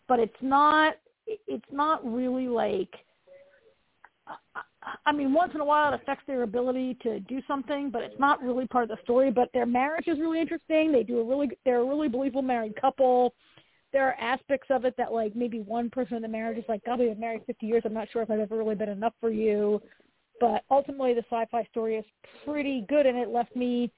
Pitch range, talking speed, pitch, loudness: 230-275 Hz, 215 wpm, 250 Hz, -27 LUFS